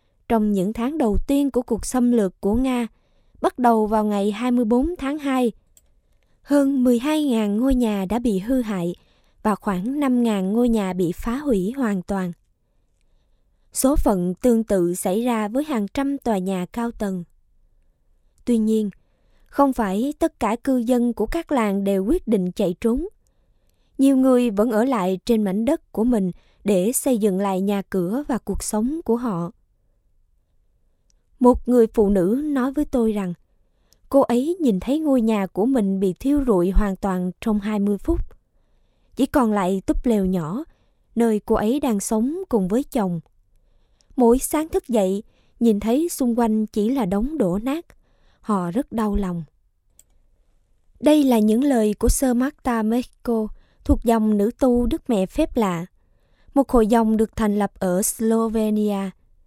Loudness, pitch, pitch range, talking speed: -21 LUFS, 220 Hz, 190-250 Hz, 165 wpm